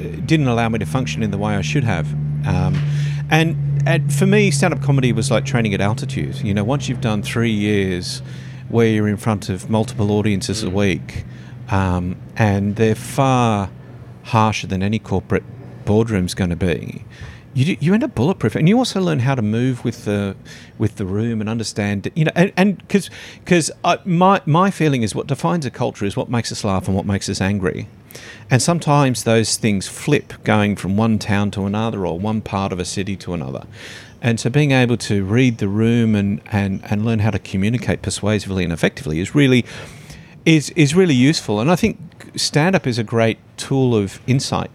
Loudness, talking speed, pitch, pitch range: -18 LUFS, 195 wpm, 115 Hz, 100-140 Hz